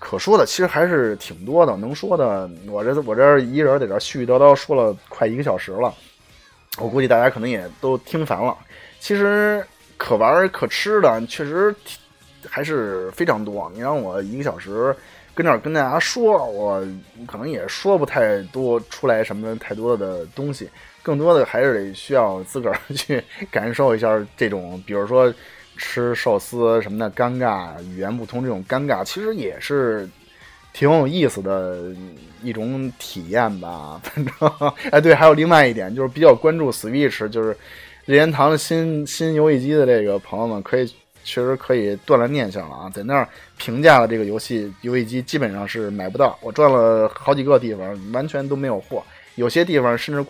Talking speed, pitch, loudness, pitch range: 280 characters per minute, 125 Hz, -19 LUFS, 110-150 Hz